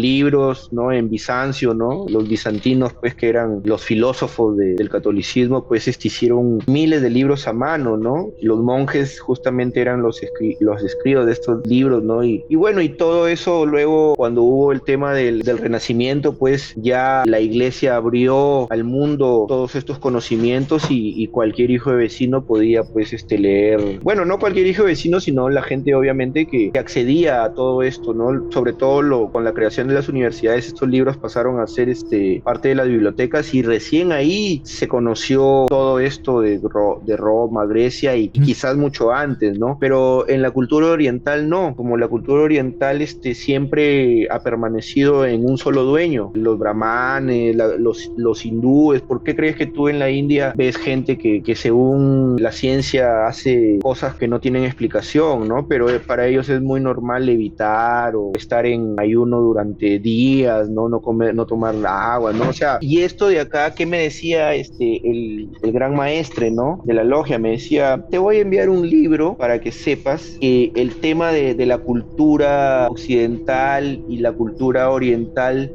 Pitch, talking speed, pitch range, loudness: 130 Hz, 185 wpm, 115-140 Hz, -17 LUFS